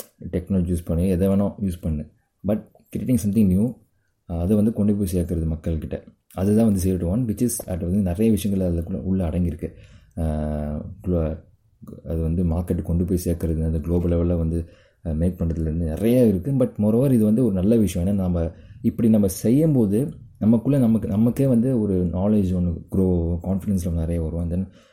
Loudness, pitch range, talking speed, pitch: -22 LUFS, 85-105 Hz, 165 wpm, 95 Hz